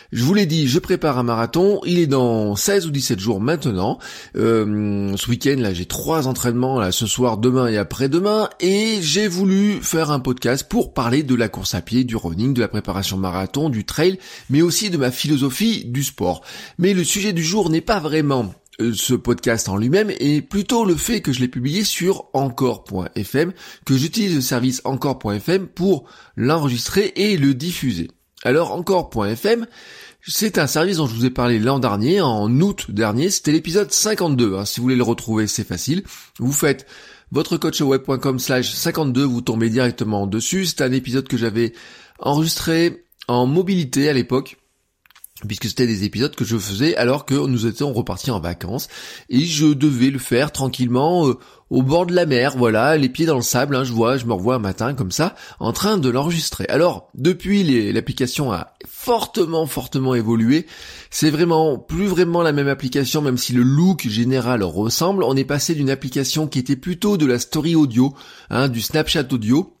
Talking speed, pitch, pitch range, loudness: 185 wpm, 135 Hz, 120-165 Hz, -19 LUFS